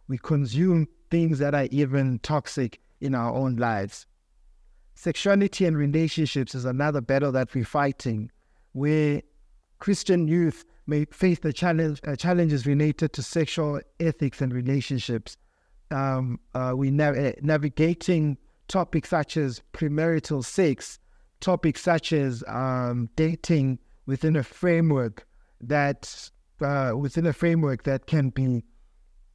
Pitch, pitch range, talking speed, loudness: 145 Hz, 130-160 Hz, 125 wpm, -25 LUFS